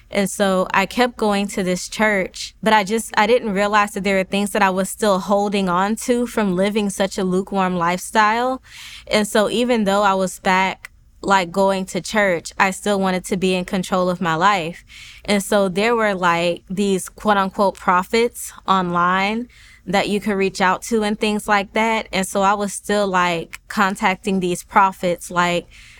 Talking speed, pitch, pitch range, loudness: 185 wpm, 200 Hz, 185-210 Hz, -19 LUFS